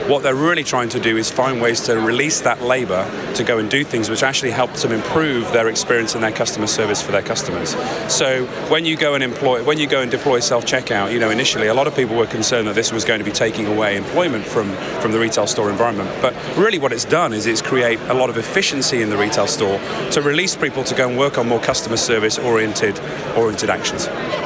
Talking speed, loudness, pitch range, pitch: 240 wpm, -17 LUFS, 115-135 Hz, 125 Hz